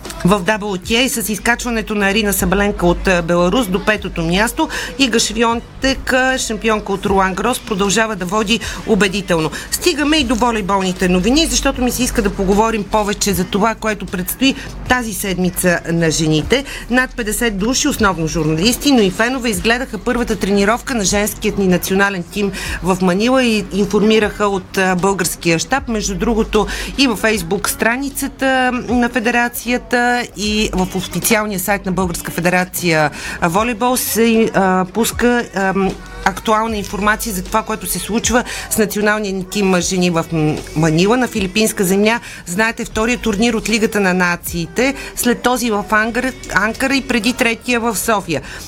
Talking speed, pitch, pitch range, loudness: 145 wpm, 215 Hz, 190-235 Hz, -16 LUFS